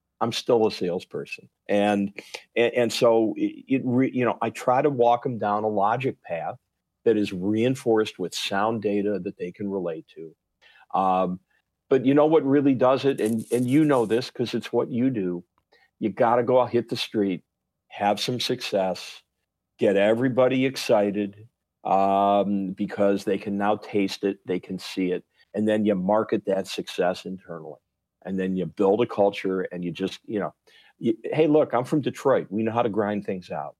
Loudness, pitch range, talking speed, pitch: -24 LUFS, 100-125 Hz, 190 wpm, 105 Hz